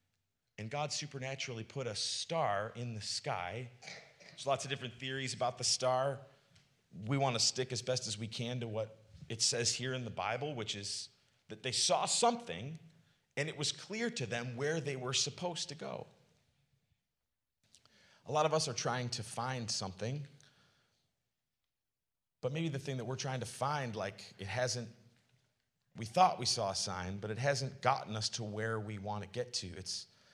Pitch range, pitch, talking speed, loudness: 110-140 Hz, 125 Hz, 180 wpm, -36 LUFS